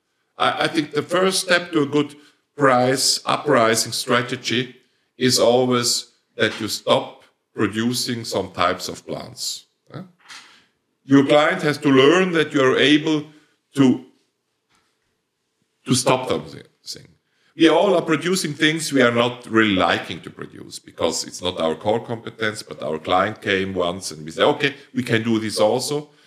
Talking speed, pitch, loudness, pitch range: 150 wpm, 130 Hz, -19 LUFS, 115-150 Hz